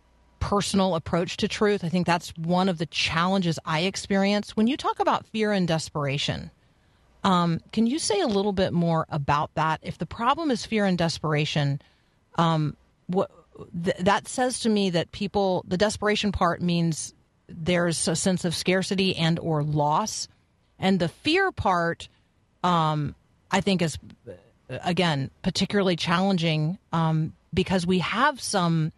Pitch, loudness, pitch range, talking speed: 175 Hz, -25 LUFS, 155-195 Hz, 155 wpm